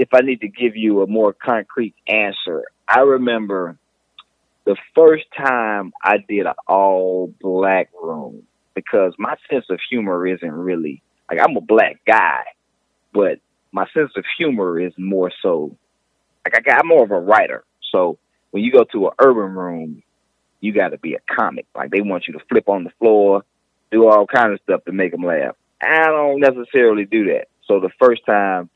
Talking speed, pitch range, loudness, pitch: 185 wpm, 95-155 Hz, -17 LUFS, 110 Hz